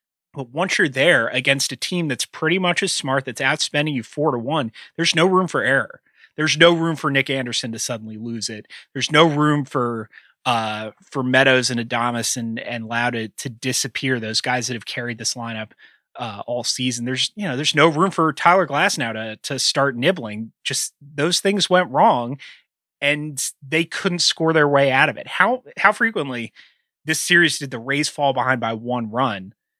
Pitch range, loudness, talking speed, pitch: 120-160 Hz, -19 LUFS, 195 wpm, 135 Hz